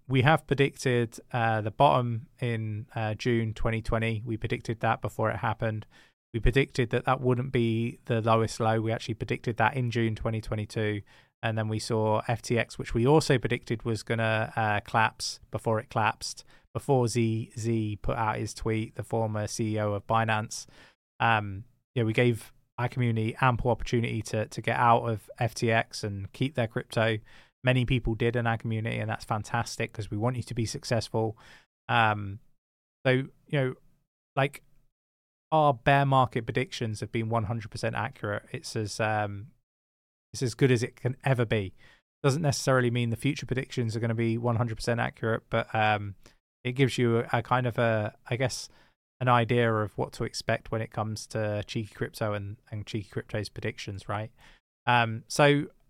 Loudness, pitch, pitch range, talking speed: -28 LUFS, 115 Hz, 110-125 Hz, 180 wpm